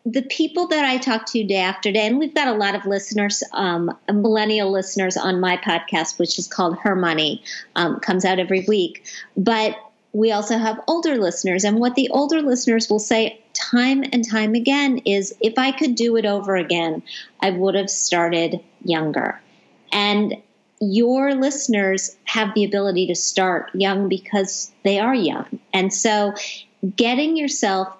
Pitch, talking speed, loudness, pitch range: 210 Hz, 170 wpm, -20 LUFS, 190-240 Hz